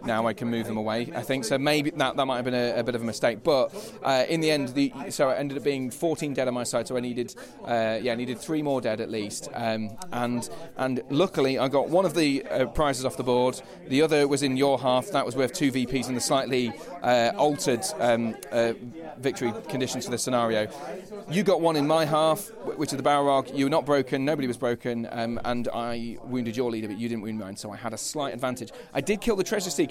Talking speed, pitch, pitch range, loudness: 255 wpm, 130 Hz, 120-145 Hz, -26 LUFS